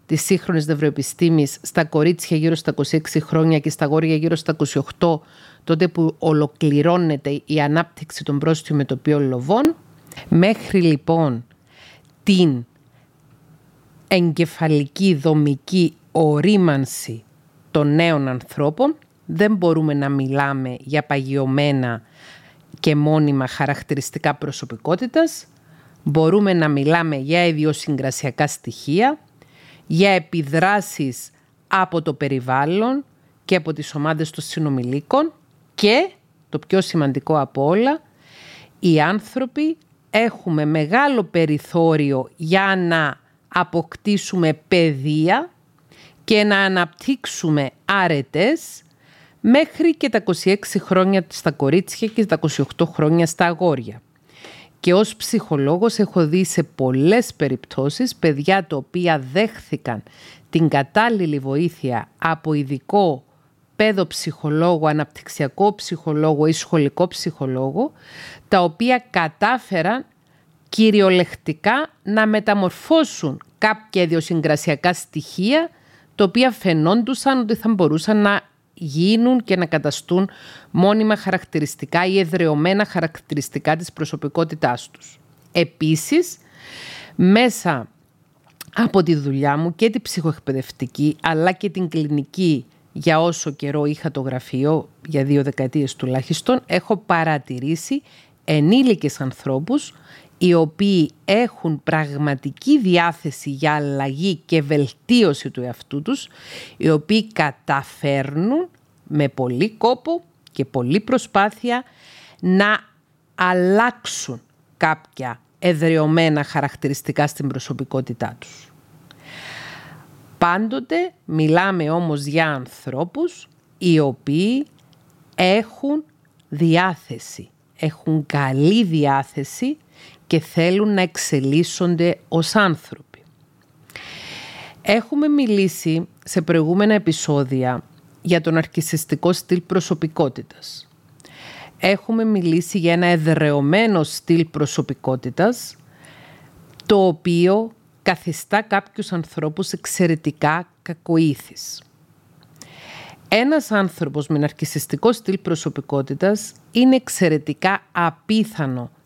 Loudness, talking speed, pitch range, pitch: -19 LUFS, 95 wpm, 150-190 Hz, 160 Hz